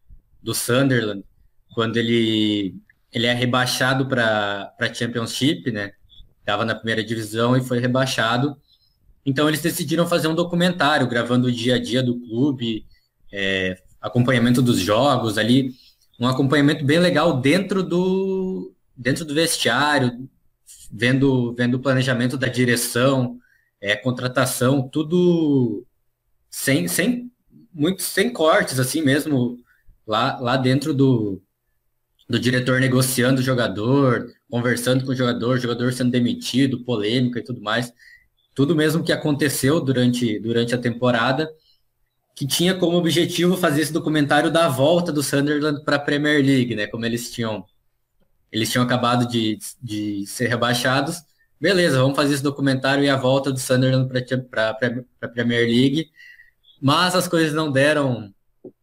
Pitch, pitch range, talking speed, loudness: 130 Hz, 120-145 Hz, 140 wpm, -20 LUFS